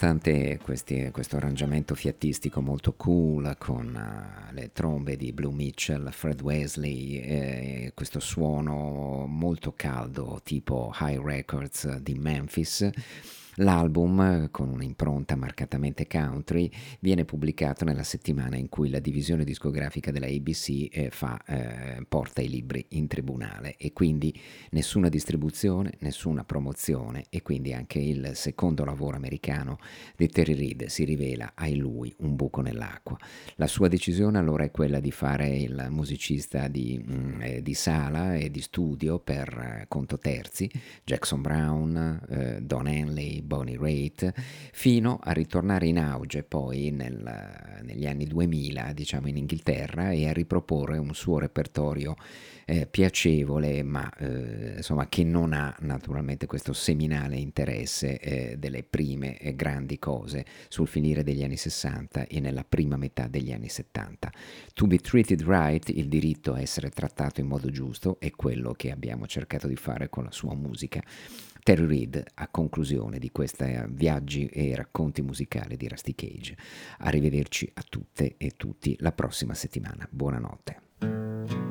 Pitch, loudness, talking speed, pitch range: 75 Hz, -29 LUFS, 140 wpm, 70-80 Hz